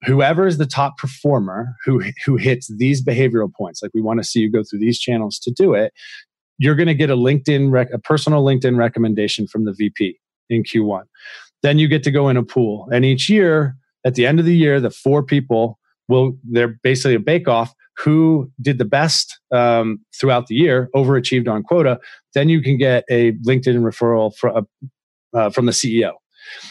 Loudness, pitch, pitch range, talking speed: -17 LUFS, 130 Hz, 115-145 Hz, 200 wpm